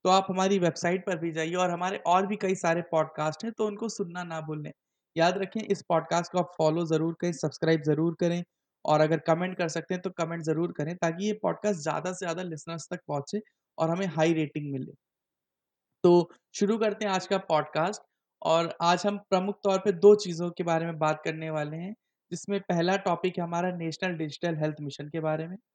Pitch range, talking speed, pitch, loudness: 160-190 Hz, 210 wpm, 175 Hz, -28 LUFS